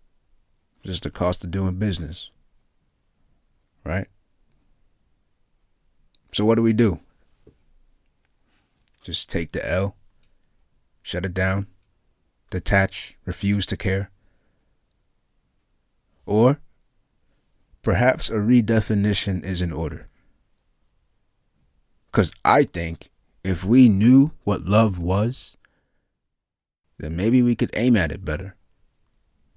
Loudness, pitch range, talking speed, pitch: -22 LUFS, 85-110 Hz, 95 wpm, 95 Hz